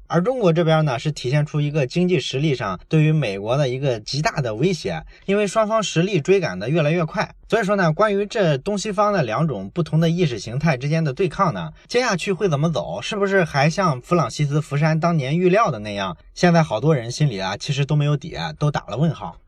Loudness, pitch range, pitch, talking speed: -20 LUFS, 150-185 Hz, 165 Hz, 350 characters per minute